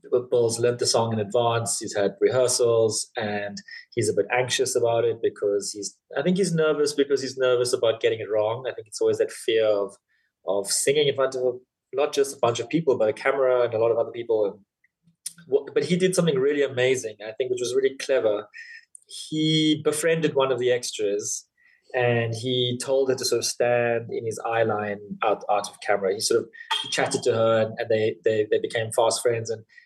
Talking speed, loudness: 210 wpm, -24 LUFS